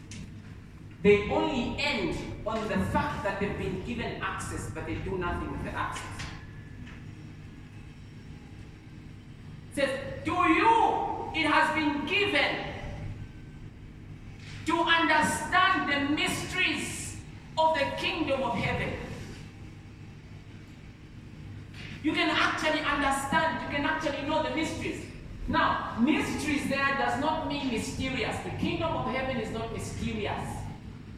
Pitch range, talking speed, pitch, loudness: 275-330 Hz, 115 wpm, 310 Hz, -28 LUFS